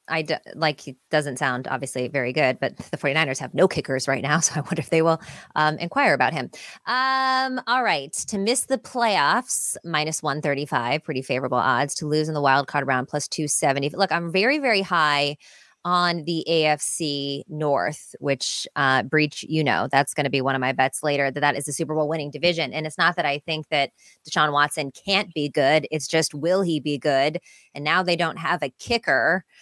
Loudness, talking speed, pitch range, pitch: -23 LUFS, 210 wpm, 140-170 Hz, 150 Hz